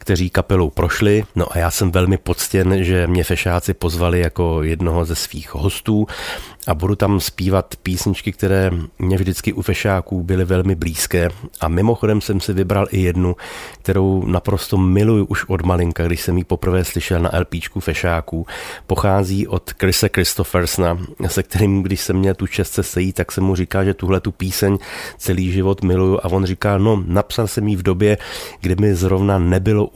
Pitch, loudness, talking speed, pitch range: 95 Hz, -18 LUFS, 175 wpm, 90-100 Hz